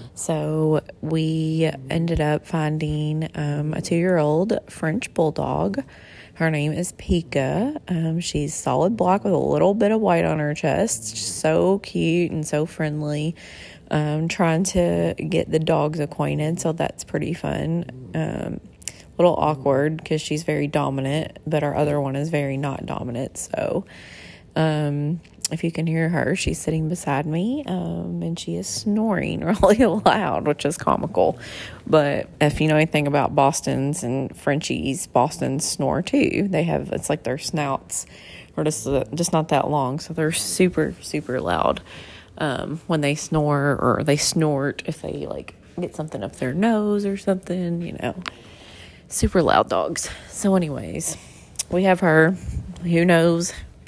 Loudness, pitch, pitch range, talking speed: -22 LUFS, 155 Hz, 145-170 Hz, 155 wpm